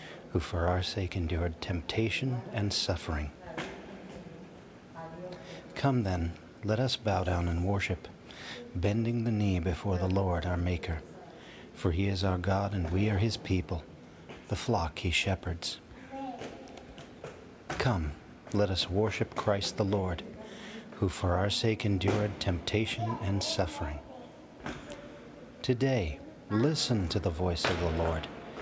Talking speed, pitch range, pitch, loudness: 130 wpm, 85-110 Hz, 95 Hz, -32 LUFS